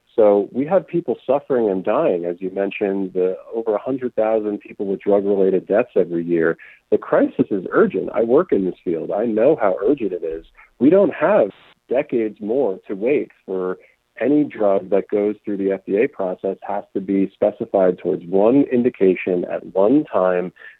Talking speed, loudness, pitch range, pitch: 175 wpm, -19 LUFS, 95-110 Hz, 100 Hz